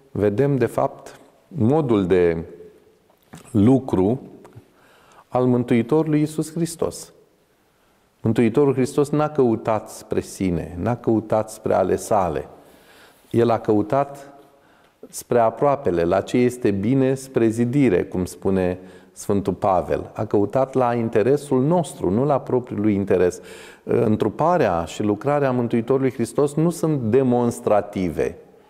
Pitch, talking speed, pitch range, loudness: 125 Hz, 115 wpm, 110-140 Hz, -21 LUFS